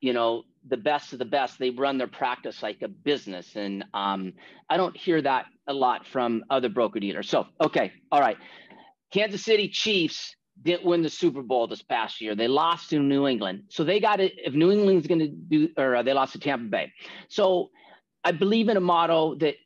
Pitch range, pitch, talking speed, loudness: 125-190 Hz, 155 Hz, 210 wpm, -25 LUFS